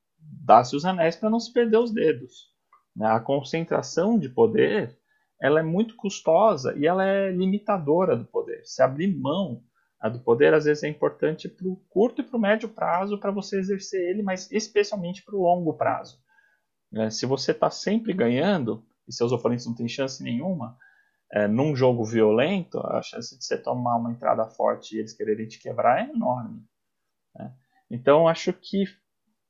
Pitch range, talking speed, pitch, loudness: 135-215 Hz, 170 wpm, 185 Hz, -24 LUFS